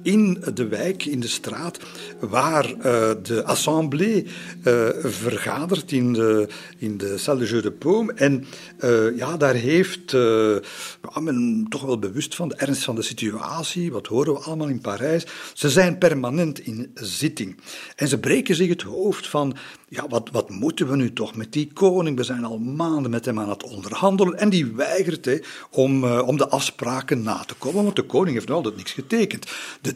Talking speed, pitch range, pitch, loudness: 190 wpm, 120-175 Hz, 140 Hz, -22 LUFS